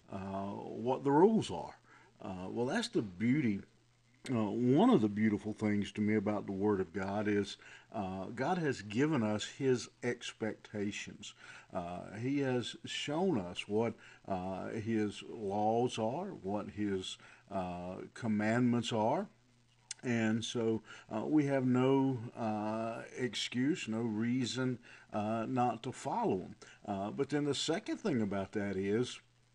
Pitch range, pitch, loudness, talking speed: 105-125 Hz, 110 Hz, -35 LUFS, 140 wpm